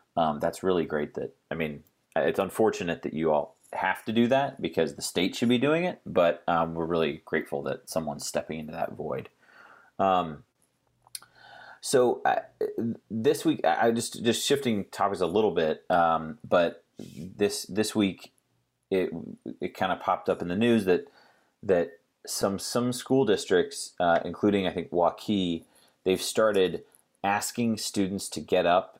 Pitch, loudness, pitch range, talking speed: 105 Hz, -27 LUFS, 85-130 Hz, 165 wpm